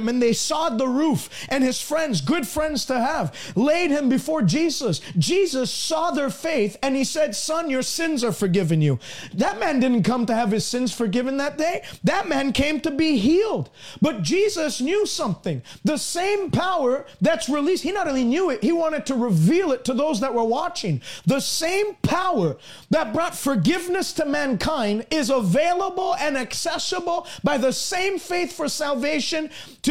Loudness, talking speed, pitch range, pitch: -22 LUFS, 175 wpm, 245-330 Hz, 290 Hz